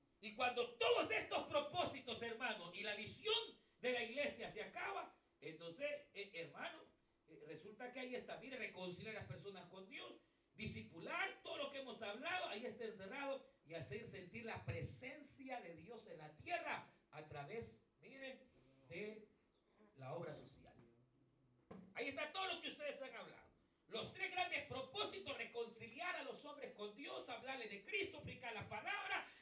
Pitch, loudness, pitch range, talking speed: 240 Hz, -47 LUFS, 200-290 Hz, 160 wpm